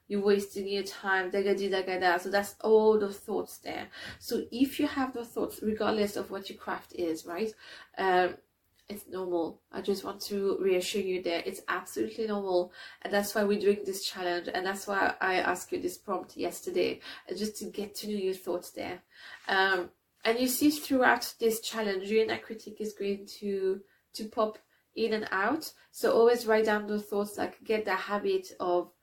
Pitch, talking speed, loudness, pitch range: 205 Hz, 185 wpm, -30 LUFS, 190-220 Hz